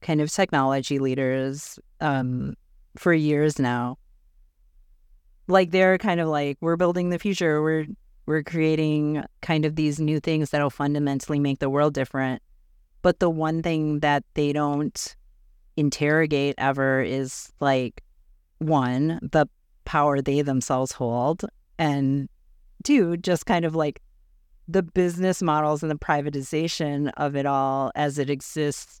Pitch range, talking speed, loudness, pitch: 135-160 Hz, 135 wpm, -24 LUFS, 150 Hz